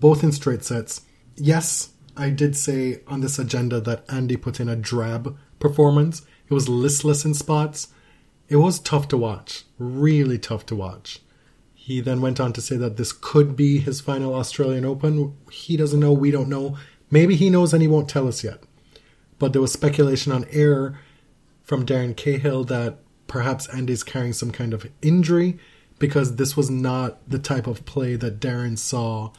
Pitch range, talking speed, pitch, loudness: 125-145 Hz, 180 wpm, 135 Hz, -21 LUFS